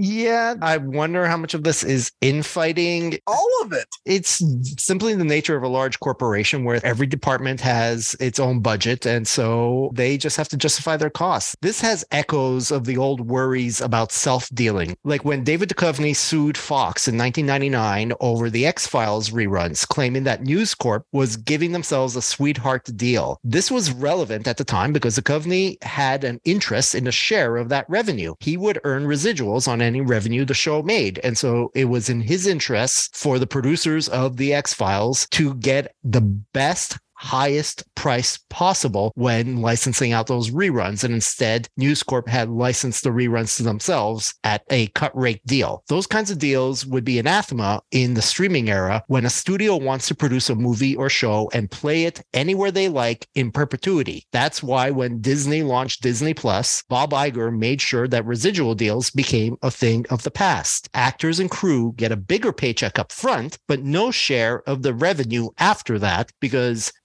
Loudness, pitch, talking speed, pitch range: -20 LUFS, 130 Hz, 185 wpm, 120-150 Hz